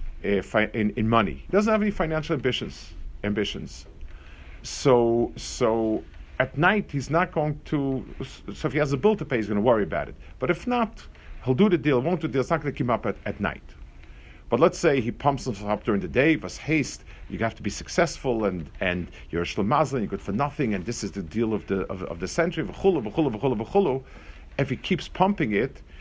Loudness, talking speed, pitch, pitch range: -25 LUFS, 225 wpm, 115 Hz, 95-155 Hz